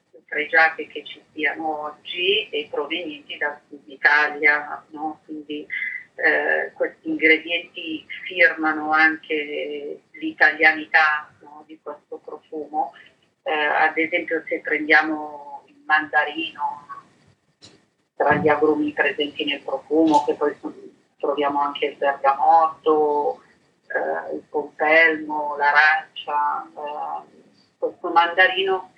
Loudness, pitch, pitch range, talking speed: -20 LUFS, 155 Hz, 150-185 Hz, 100 wpm